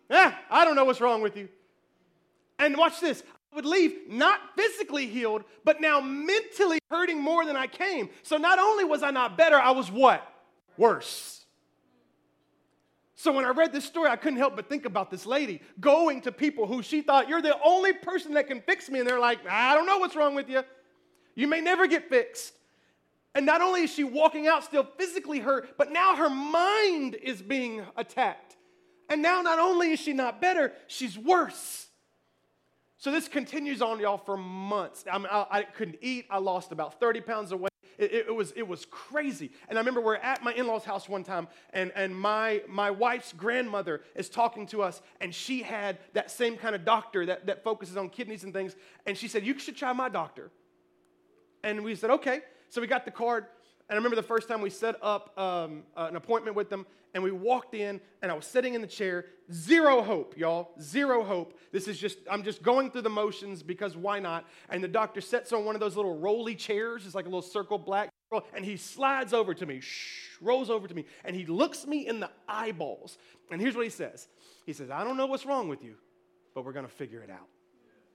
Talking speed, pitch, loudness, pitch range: 215 wpm, 235 Hz, -28 LUFS, 200-295 Hz